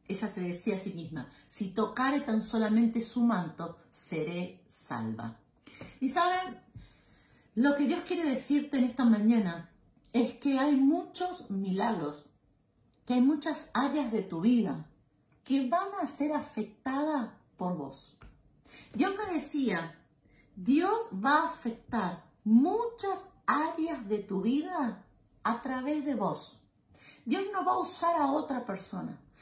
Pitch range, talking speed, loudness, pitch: 195-295 Hz, 135 wpm, -31 LUFS, 245 Hz